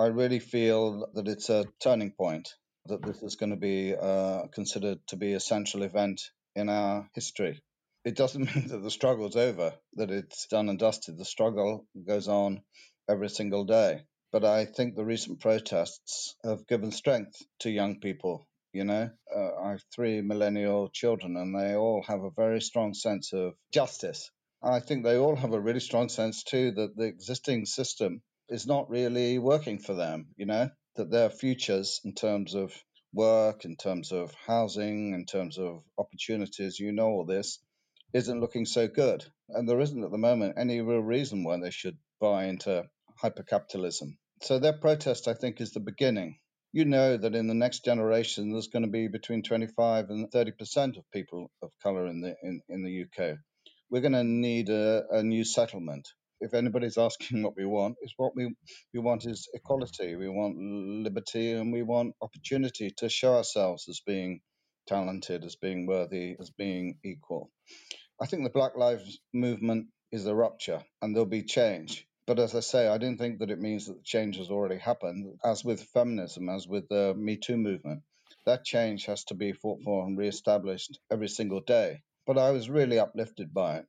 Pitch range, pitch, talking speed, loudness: 100-120 Hz, 110 Hz, 190 wpm, -30 LUFS